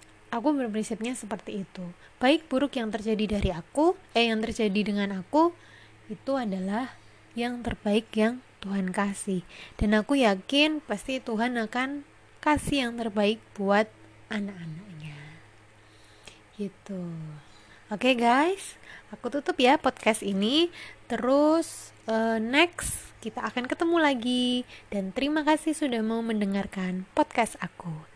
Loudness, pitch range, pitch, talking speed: -27 LUFS, 200-260 Hz, 225 Hz, 120 wpm